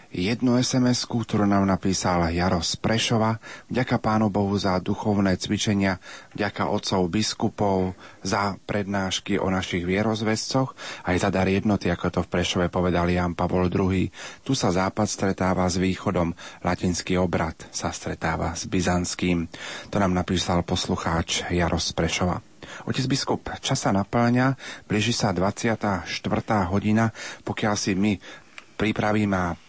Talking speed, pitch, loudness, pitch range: 130 wpm, 100 Hz, -24 LUFS, 90-110 Hz